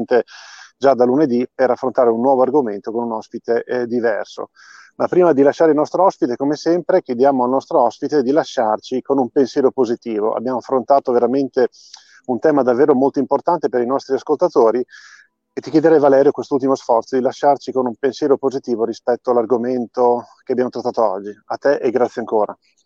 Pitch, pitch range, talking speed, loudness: 130 Hz, 120-140 Hz, 175 wpm, -17 LUFS